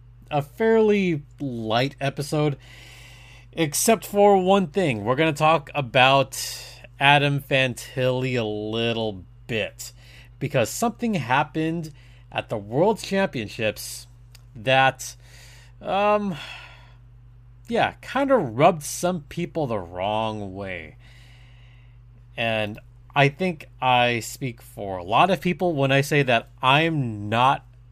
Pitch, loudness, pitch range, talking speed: 125 Hz, -22 LUFS, 120-150 Hz, 110 wpm